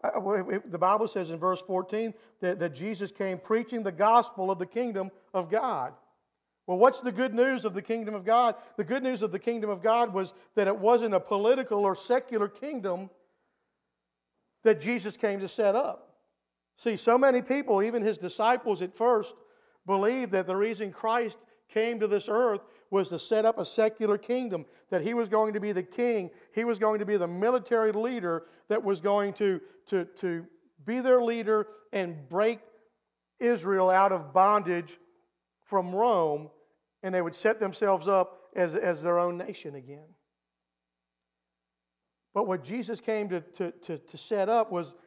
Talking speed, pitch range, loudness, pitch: 175 wpm, 180-225 Hz, -28 LUFS, 205 Hz